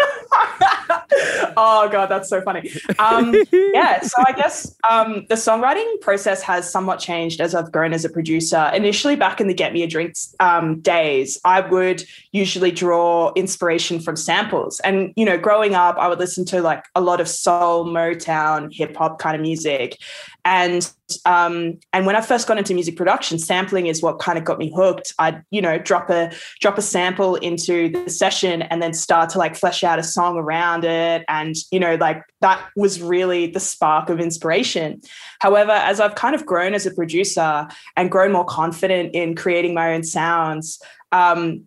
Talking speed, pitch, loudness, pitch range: 185 wpm, 180 Hz, -18 LUFS, 165-195 Hz